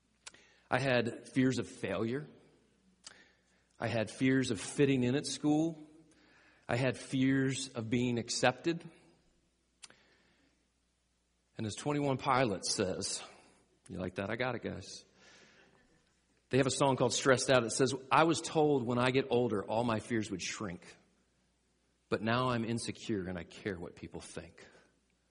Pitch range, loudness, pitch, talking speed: 105-135 Hz, -33 LUFS, 125 Hz, 150 wpm